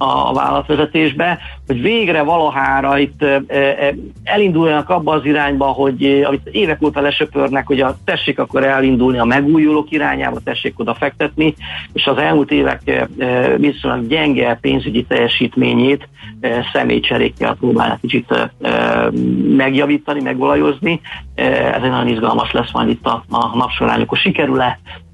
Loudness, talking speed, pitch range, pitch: -15 LUFS, 120 wpm, 130-150 Hz, 140 Hz